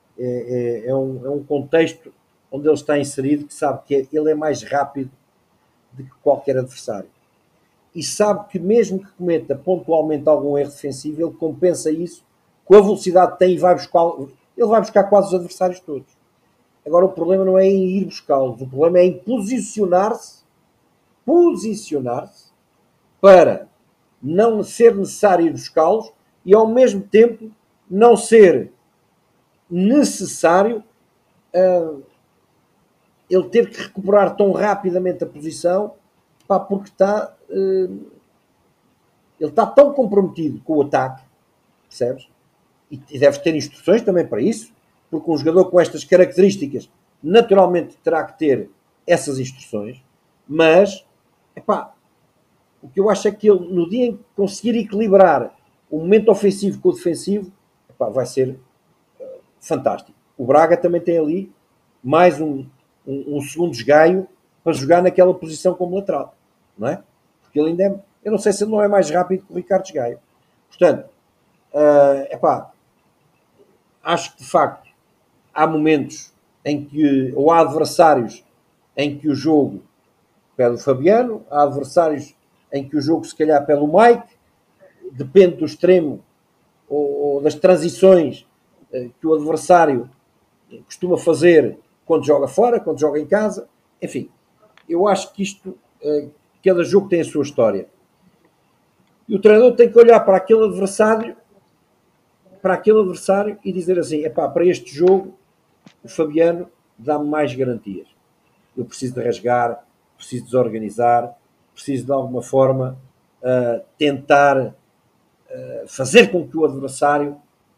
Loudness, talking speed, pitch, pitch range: -17 LUFS, 145 wpm, 170 Hz, 145-195 Hz